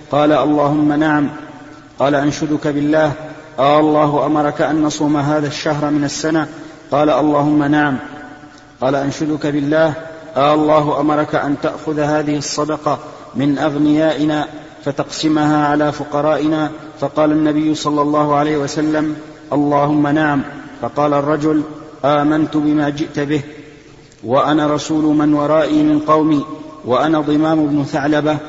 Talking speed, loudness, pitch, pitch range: 120 wpm, -16 LUFS, 150 Hz, 145-155 Hz